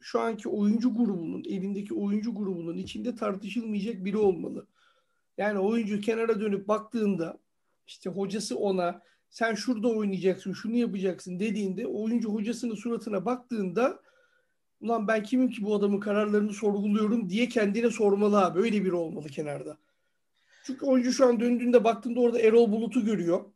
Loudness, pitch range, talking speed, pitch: -28 LUFS, 200-240 Hz, 140 wpm, 215 Hz